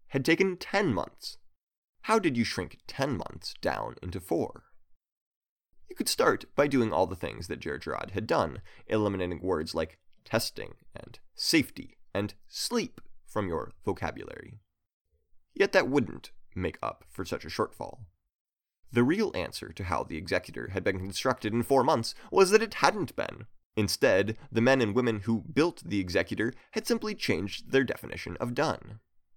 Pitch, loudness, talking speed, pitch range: 115 Hz, -30 LUFS, 160 wpm, 95-135 Hz